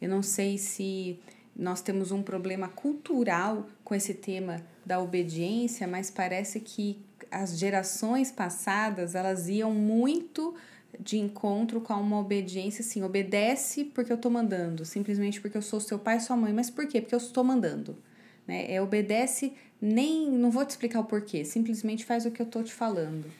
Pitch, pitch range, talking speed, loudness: 210 Hz, 195-235 Hz, 175 wpm, -30 LUFS